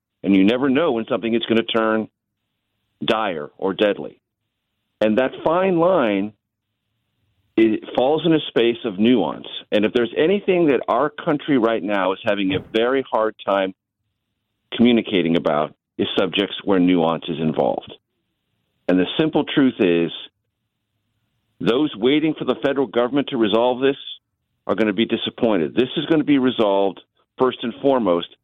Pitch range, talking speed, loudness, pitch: 105-125 Hz, 160 wpm, -20 LUFS, 110 Hz